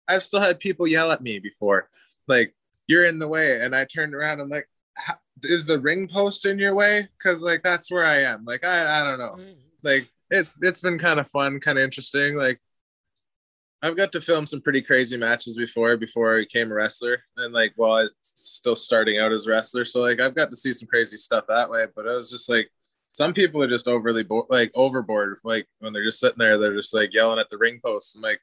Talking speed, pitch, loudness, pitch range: 240 wpm, 135 Hz, -22 LUFS, 115-170 Hz